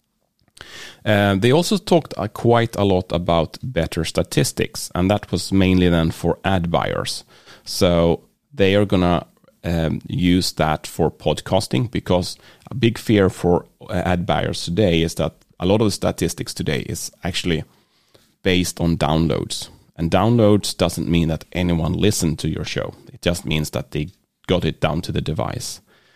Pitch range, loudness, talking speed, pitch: 85-100 Hz, -20 LUFS, 160 wpm, 90 Hz